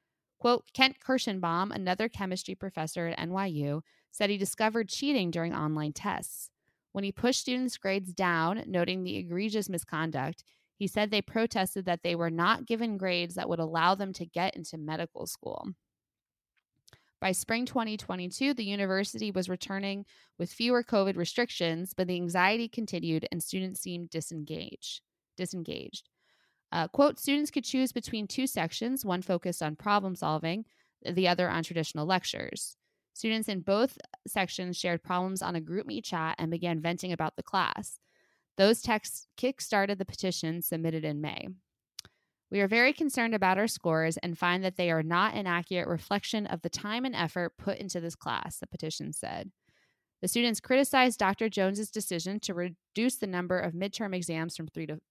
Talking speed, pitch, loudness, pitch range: 165 wpm, 185 Hz, -31 LUFS, 170-215 Hz